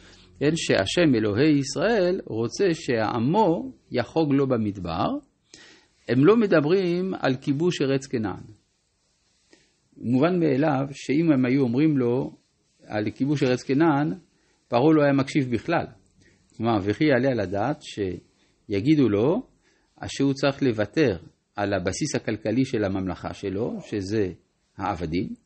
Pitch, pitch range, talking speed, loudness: 130 Hz, 105-150 Hz, 120 wpm, -24 LUFS